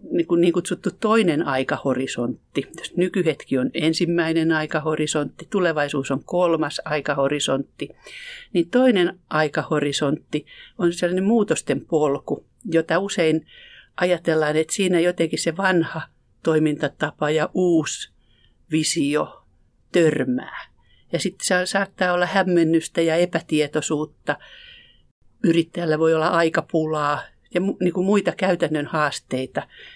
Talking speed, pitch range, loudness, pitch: 95 wpm, 155-180 Hz, -22 LUFS, 165 Hz